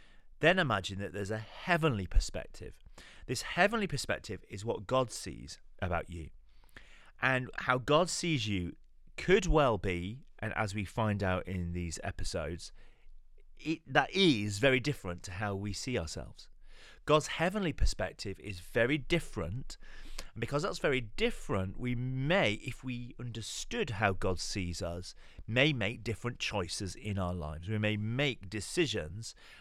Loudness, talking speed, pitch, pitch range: -33 LUFS, 150 wpm, 110 Hz, 95-130 Hz